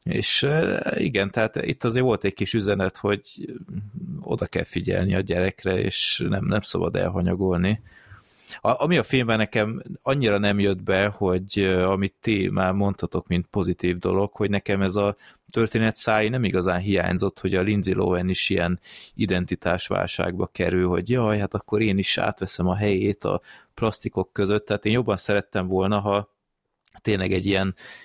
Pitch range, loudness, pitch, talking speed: 95-105 Hz, -23 LUFS, 100 Hz, 160 wpm